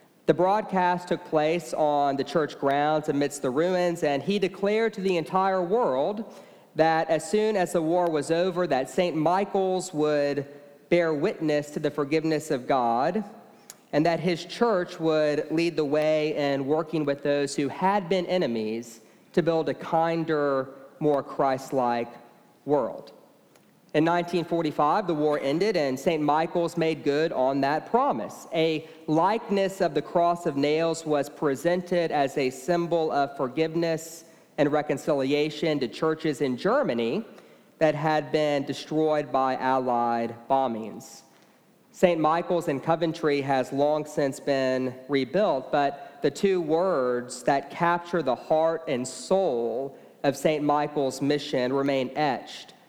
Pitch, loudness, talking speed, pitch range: 155 Hz, -26 LUFS, 140 wpm, 145-175 Hz